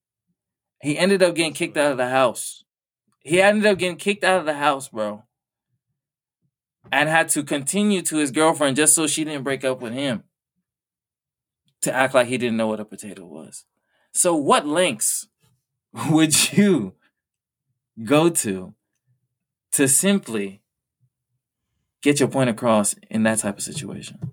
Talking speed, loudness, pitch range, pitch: 155 wpm, -20 LUFS, 120-160 Hz, 135 Hz